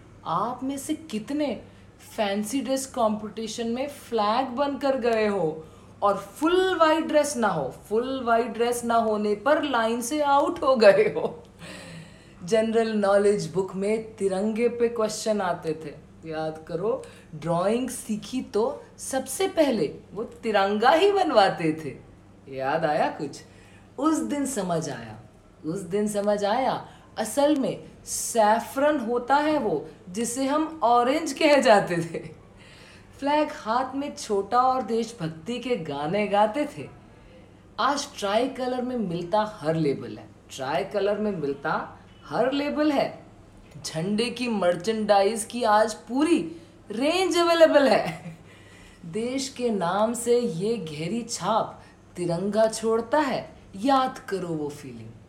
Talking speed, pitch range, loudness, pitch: 130 wpm, 175-265 Hz, -25 LUFS, 220 Hz